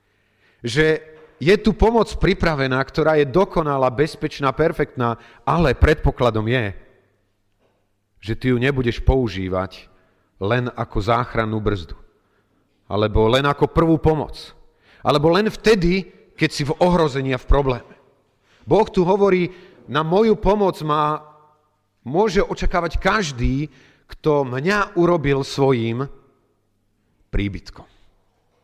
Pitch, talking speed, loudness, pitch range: 135 Hz, 110 wpm, -19 LUFS, 110-160 Hz